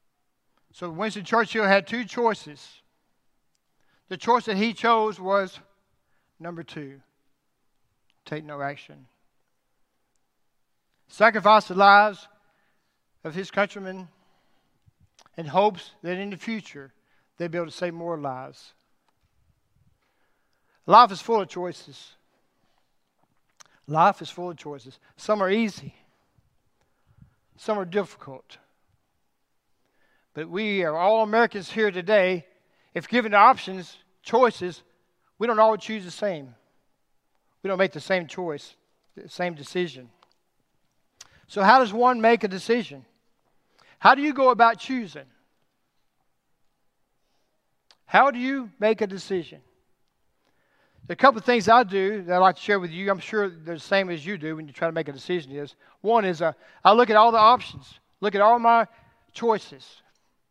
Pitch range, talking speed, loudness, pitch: 165-215 Hz, 140 wpm, -22 LUFS, 195 Hz